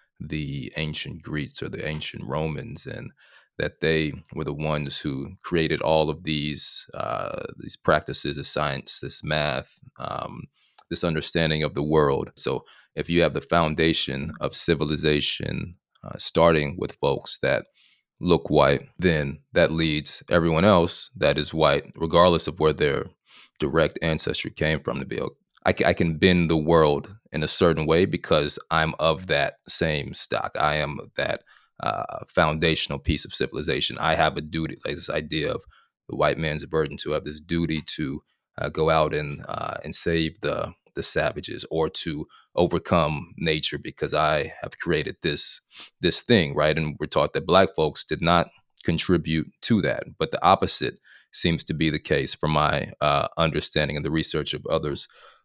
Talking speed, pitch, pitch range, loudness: 170 wpm, 80 Hz, 75-80 Hz, -24 LUFS